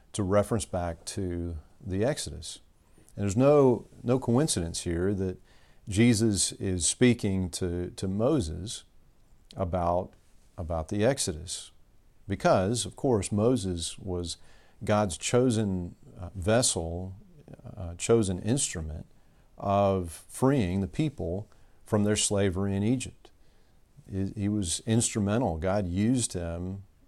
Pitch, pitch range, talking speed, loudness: 100 Hz, 90-115 Hz, 110 wpm, -28 LUFS